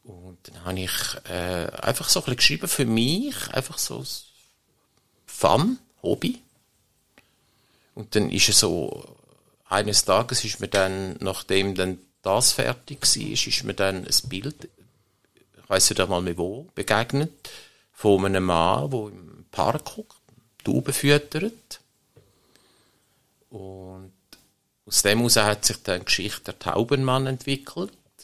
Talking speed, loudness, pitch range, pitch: 130 wpm, -23 LUFS, 95-135 Hz, 105 Hz